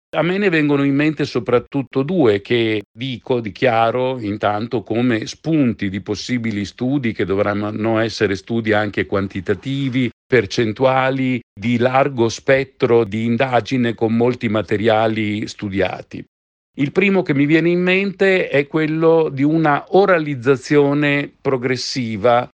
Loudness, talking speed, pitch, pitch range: -18 LUFS, 120 wpm, 125 Hz, 110-140 Hz